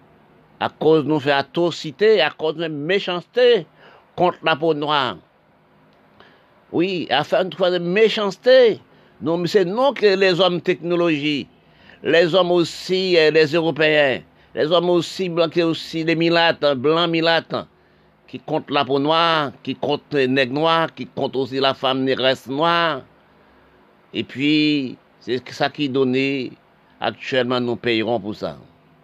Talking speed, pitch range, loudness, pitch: 145 wpm, 135-175 Hz, -19 LUFS, 160 Hz